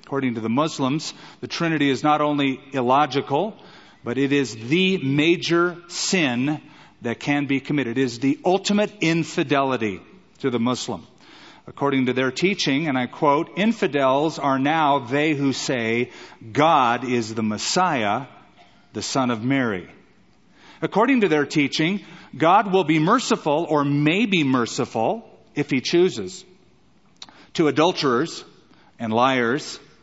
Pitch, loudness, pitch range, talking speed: 145 Hz, -21 LUFS, 130-170 Hz, 135 wpm